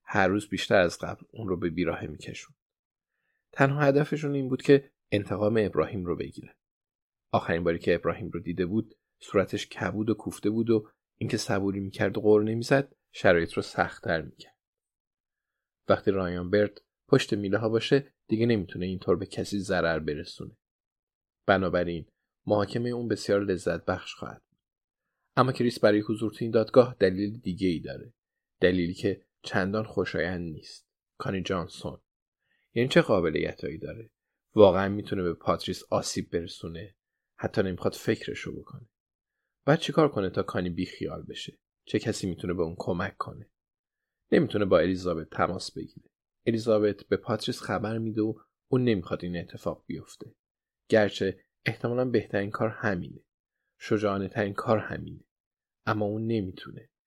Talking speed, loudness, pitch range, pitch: 145 wpm, -28 LUFS, 90-115 Hz, 105 Hz